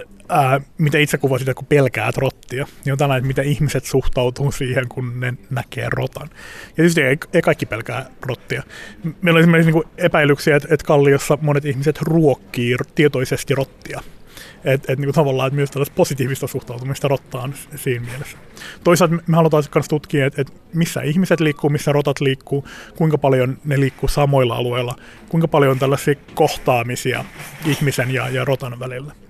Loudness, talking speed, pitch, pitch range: -18 LUFS, 170 wpm, 140 Hz, 130-155 Hz